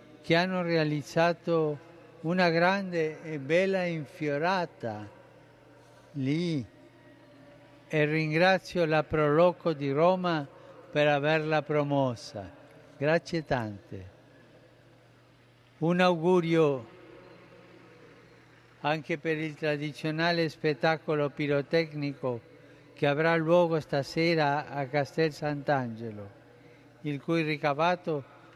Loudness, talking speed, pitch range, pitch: -28 LUFS, 80 wpm, 145-165 Hz, 150 Hz